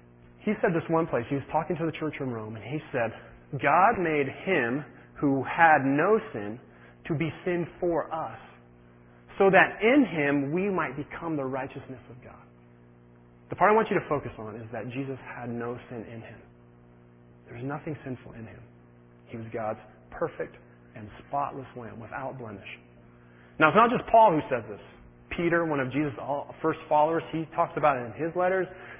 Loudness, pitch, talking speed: -27 LUFS, 130 Hz, 190 wpm